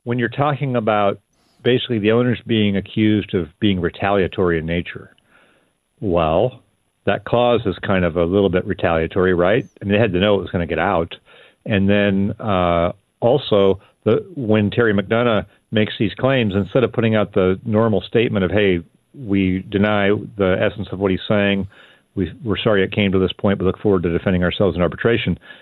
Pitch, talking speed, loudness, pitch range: 100 Hz, 190 wpm, -18 LUFS, 95-110 Hz